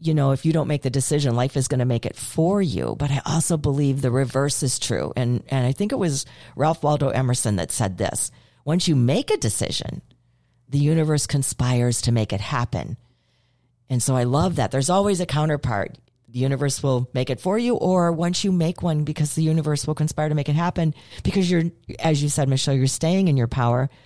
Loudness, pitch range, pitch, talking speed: -22 LUFS, 125-155 Hz, 140 Hz, 220 wpm